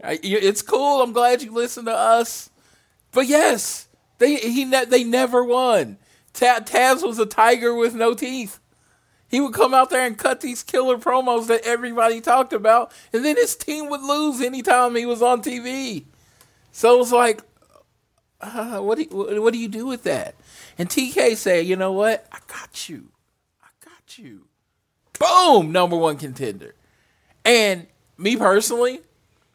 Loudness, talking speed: -19 LUFS, 160 wpm